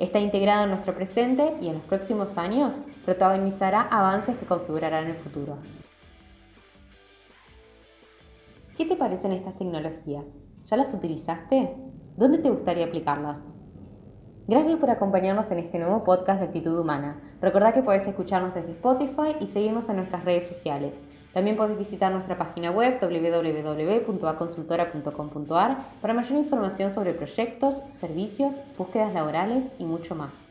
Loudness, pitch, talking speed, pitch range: -26 LUFS, 185 Hz, 135 wpm, 160-225 Hz